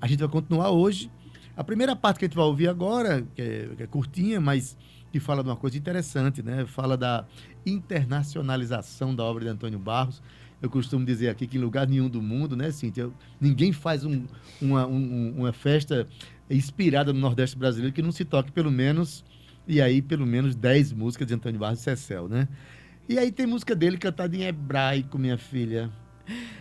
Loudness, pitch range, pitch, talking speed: -26 LUFS, 125-160 Hz, 135 Hz, 195 wpm